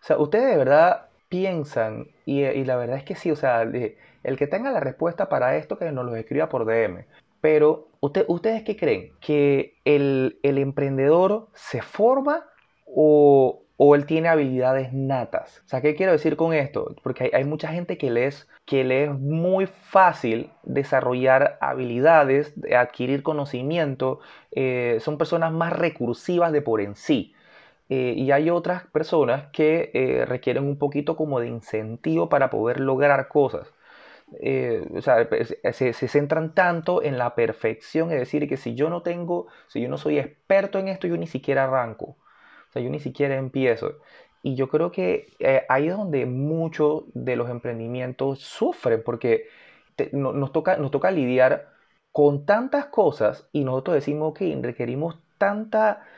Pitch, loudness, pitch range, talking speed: 145 Hz, -23 LUFS, 130-170 Hz, 170 wpm